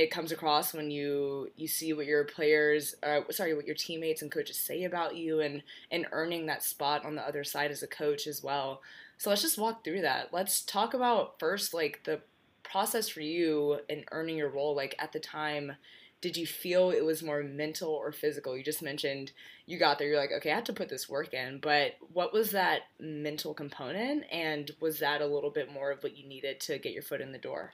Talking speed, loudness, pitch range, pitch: 230 wpm, -33 LUFS, 145-165 Hz, 150 Hz